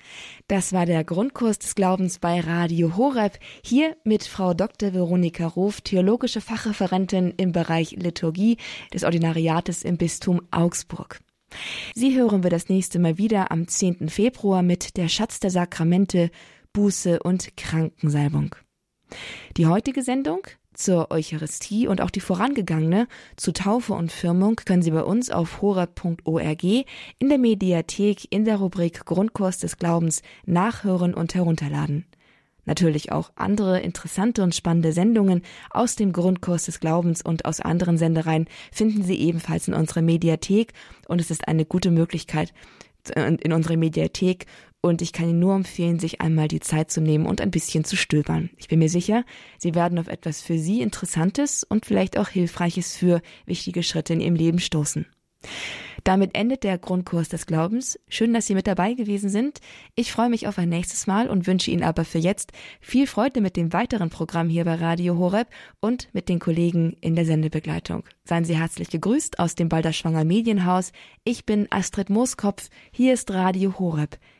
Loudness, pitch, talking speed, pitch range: -23 LUFS, 180 Hz, 165 wpm, 165-205 Hz